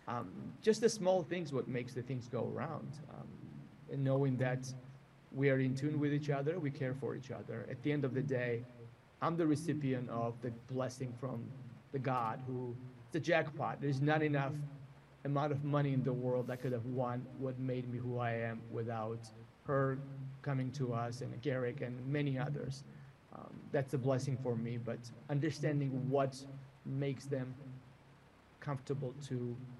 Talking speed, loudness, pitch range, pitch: 175 wpm, -38 LUFS, 125-140 Hz, 130 Hz